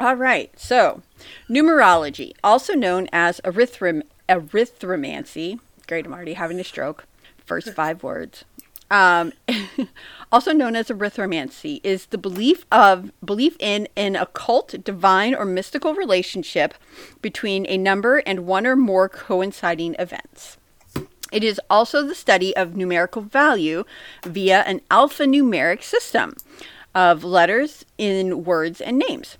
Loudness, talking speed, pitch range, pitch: -19 LUFS, 125 wpm, 185-270 Hz, 205 Hz